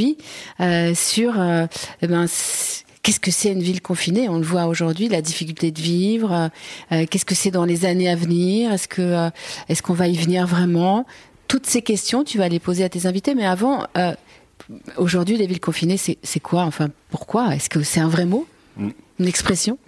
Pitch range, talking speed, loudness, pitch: 170-205 Hz, 200 wpm, -20 LUFS, 180 Hz